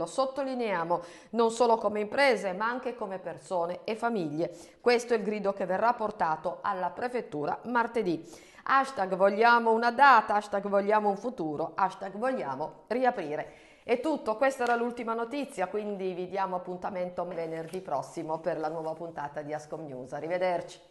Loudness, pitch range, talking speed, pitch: -29 LUFS, 170-235 Hz, 150 wpm, 195 Hz